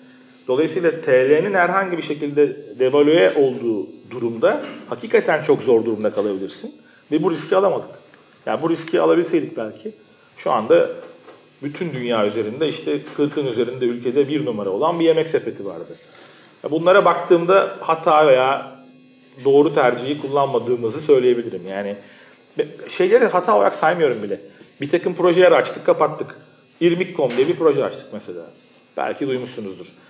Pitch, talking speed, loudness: 170 Hz, 130 wpm, -18 LUFS